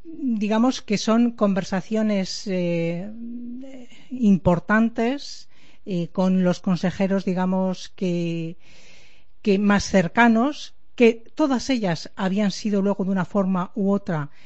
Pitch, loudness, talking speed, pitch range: 200 Hz, -22 LUFS, 110 wpm, 185-230 Hz